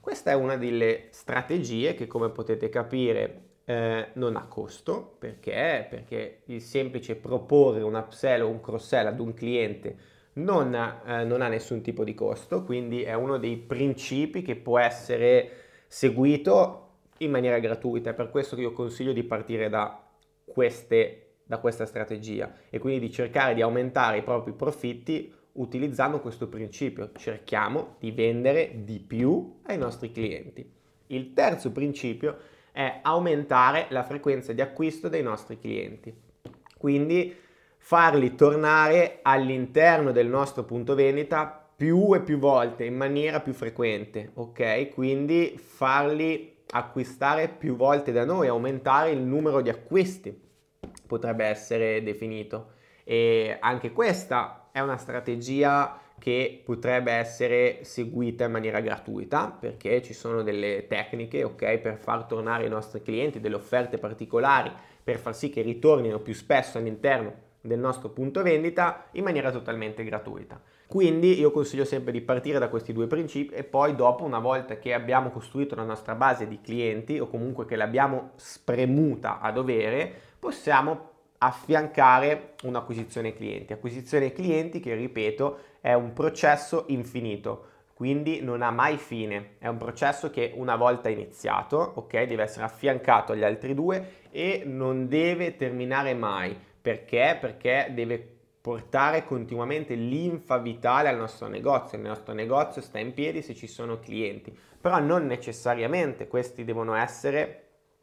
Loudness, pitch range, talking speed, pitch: -27 LUFS, 115-145 Hz, 145 wpm, 125 Hz